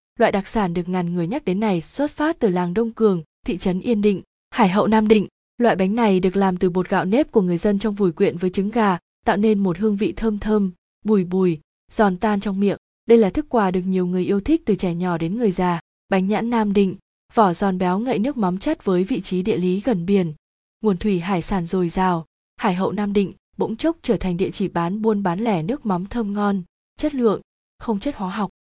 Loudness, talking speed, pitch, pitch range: -21 LUFS, 245 wpm, 200 Hz, 185-220 Hz